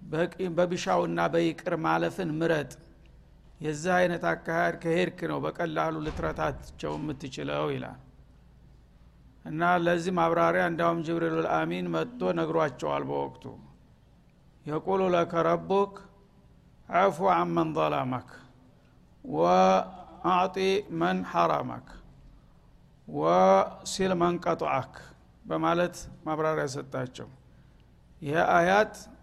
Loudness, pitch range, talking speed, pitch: -28 LUFS, 145-180 Hz, 80 wpm, 170 Hz